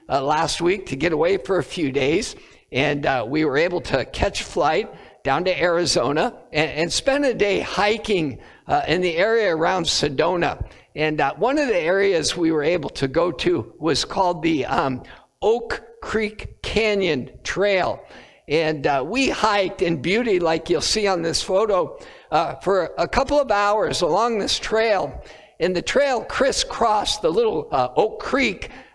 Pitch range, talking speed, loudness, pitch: 165-235 Hz, 170 wpm, -21 LUFS, 190 Hz